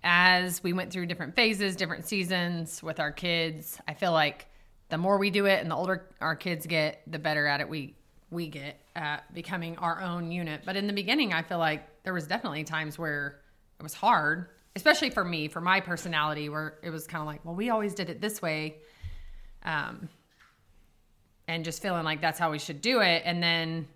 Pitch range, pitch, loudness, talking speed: 155-185 Hz, 165 Hz, -29 LUFS, 210 wpm